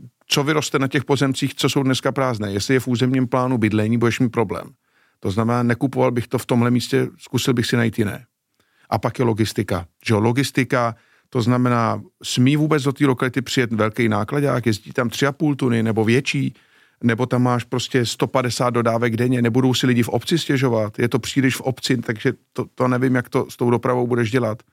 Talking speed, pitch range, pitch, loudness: 200 wpm, 115-135 Hz, 125 Hz, -20 LUFS